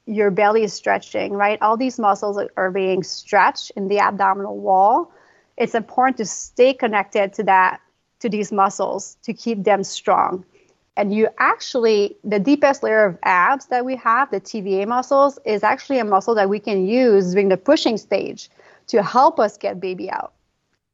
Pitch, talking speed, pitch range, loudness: 210 Hz, 175 wpm, 195-245 Hz, -19 LUFS